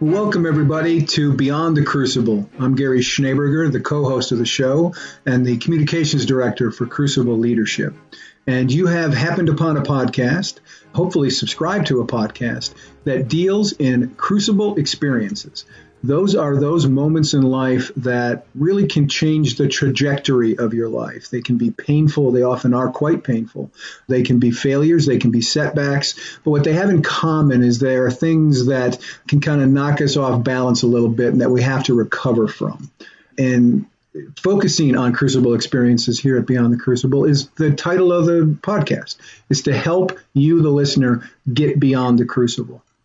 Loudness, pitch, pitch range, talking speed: -17 LUFS, 135 Hz, 125-155 Hz, 175 wpm